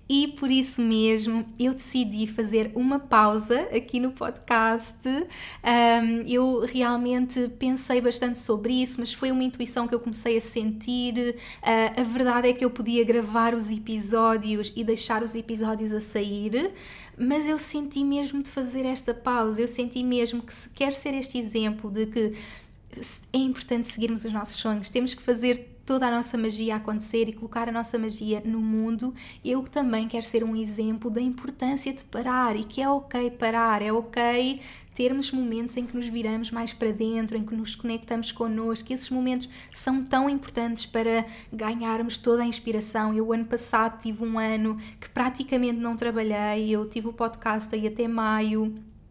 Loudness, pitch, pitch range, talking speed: -26 LUFS, 235 Hz, 225-250 Hz, 170 wpm